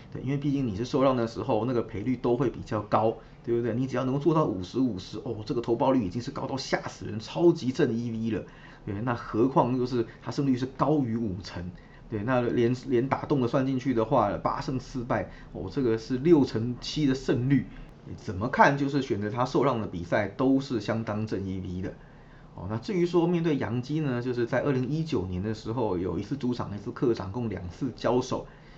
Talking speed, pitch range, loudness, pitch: 315 characters per minute, 110-140 Hz, -28 LUFS, 125 Hz